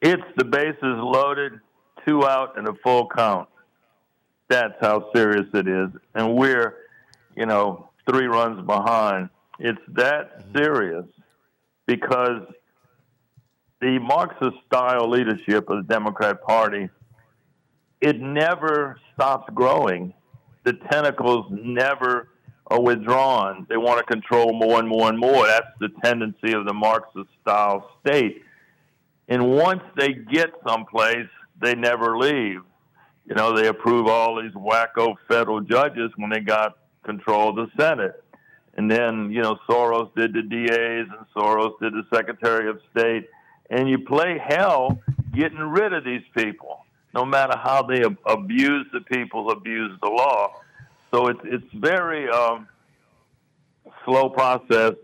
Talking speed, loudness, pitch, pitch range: 135 wpm, -21 LUFS, 120 Hz, 110-130 Hz